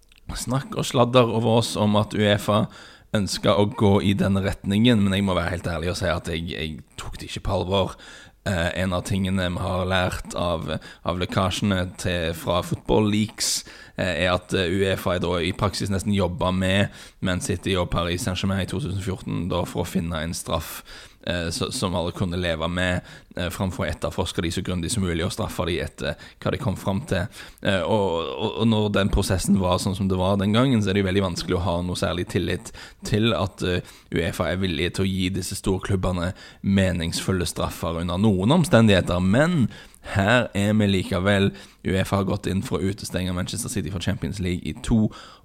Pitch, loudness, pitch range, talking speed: 95 Hz, -24 LUFS, 90-100 Hz, 190 wpm